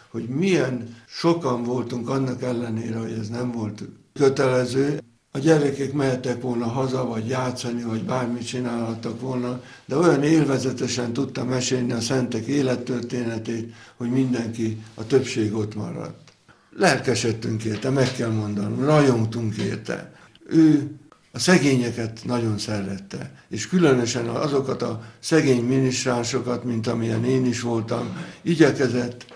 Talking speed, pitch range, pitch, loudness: 125 wpm, 115-130 Hz, 125 Hz, -23 LUFS